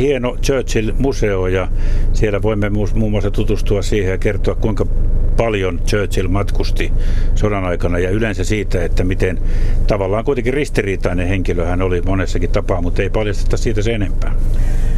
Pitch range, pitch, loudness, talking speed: 95-110 Hz, 100 Hz, -18 LUFS, 145 wpm